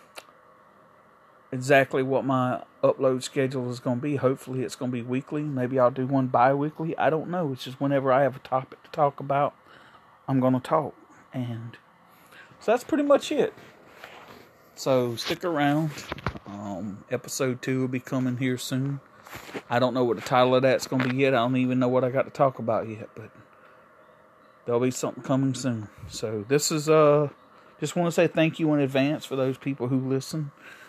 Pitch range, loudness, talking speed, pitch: 125-145 Hz, -25 LUFS, 185 wpm, 130 Hz